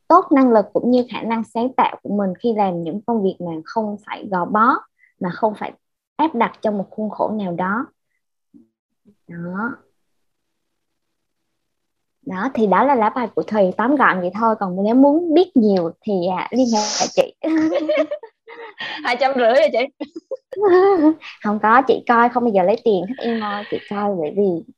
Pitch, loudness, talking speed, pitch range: 230 Hz, -18 LUFS, 190 wpm, 200-285 Hz